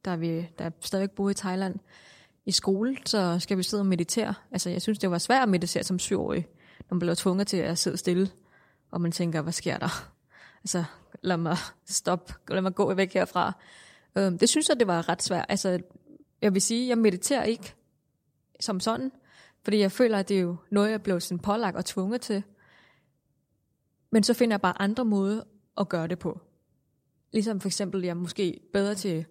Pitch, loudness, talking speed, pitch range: 190 Hz, -27 LUFS, 205 wpm, 175-210 Hz